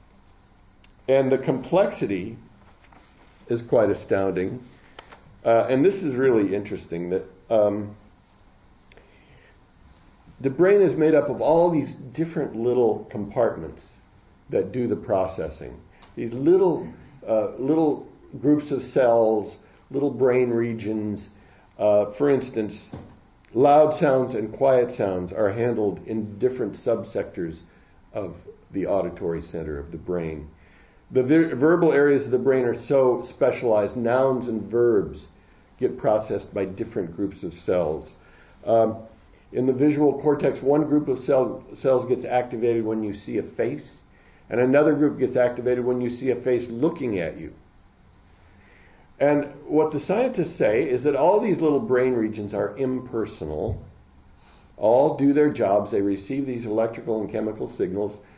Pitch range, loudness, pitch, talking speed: 100-140 Hz, -23 LUFS, 120 Hz, 140 wpm